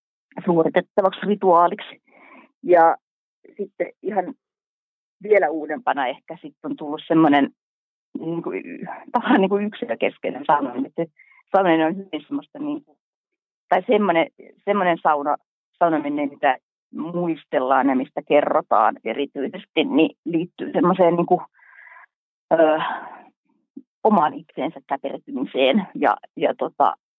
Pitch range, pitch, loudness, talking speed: 155-220 Hz, 175 Hz, -21 LUFS, 105 wpm